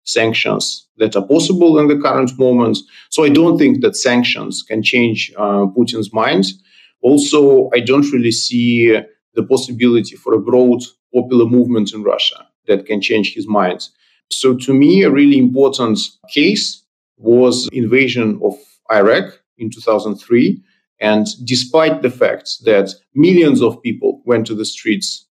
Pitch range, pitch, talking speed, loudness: 115-150 Hz, 125 Hz, 150 wpm, -14 LUFS